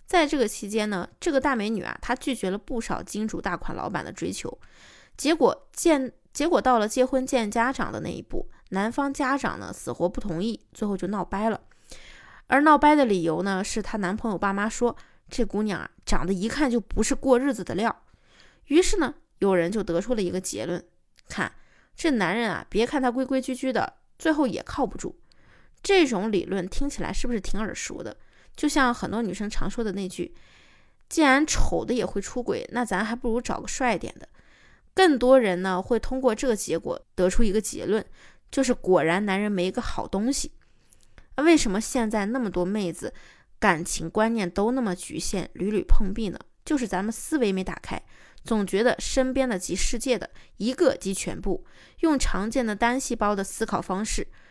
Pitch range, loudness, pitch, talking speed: 195-260 Hz, -26 LUFS, 220 Hz, 280 characters per minute